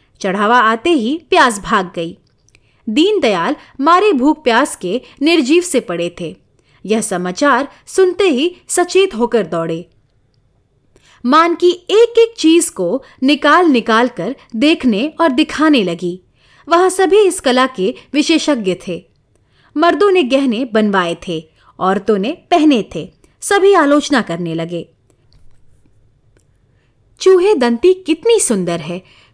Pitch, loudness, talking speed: 255 Hz, -13 LUFS, 125 wpm